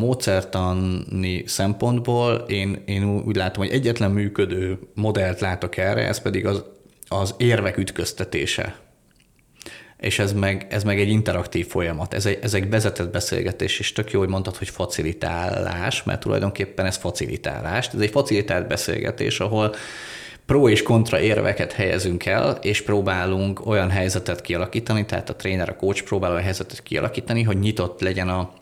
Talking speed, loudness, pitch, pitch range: 145 wpm, -23 LUFS, 100 Hz, 95-110 Hz